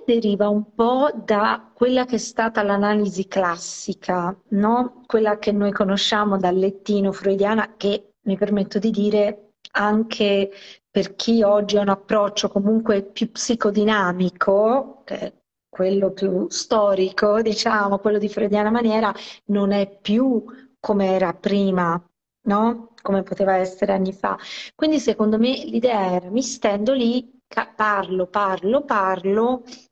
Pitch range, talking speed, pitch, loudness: 195-225 Hz, 130 wpm, 210 Hz, -21 LUFS